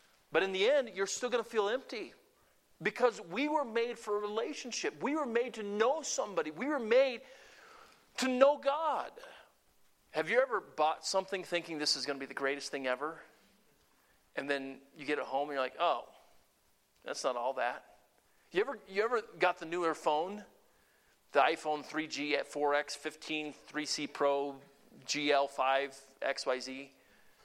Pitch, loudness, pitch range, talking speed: 165 Hz, -34 LUFS, 145-240 Hz, 165 wpm